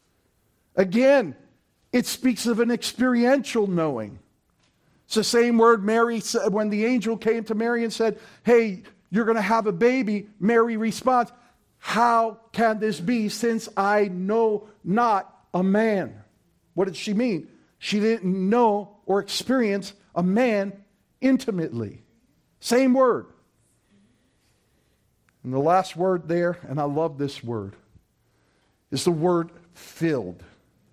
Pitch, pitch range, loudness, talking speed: 210 Hz, 175-230 Hz, -23 LUFS, 130 wpm